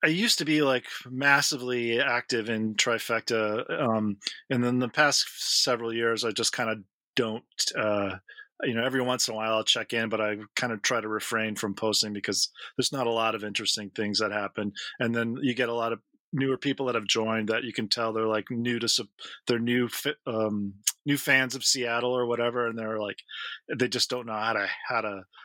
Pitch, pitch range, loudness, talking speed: 115 Hz, 110-125 Hz, -27 LUFS, 210 wpm